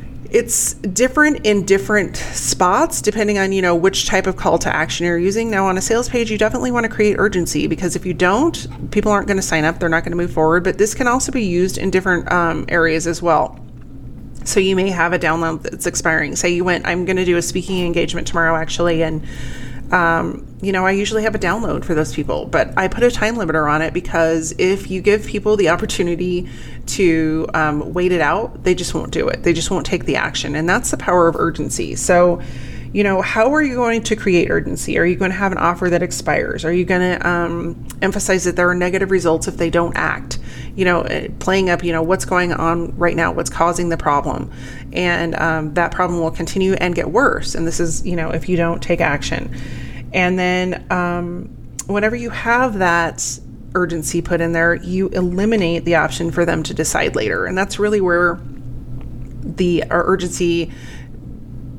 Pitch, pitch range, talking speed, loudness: 175 Hz, 165-190 Hz, 215 wpm, -17 LUFS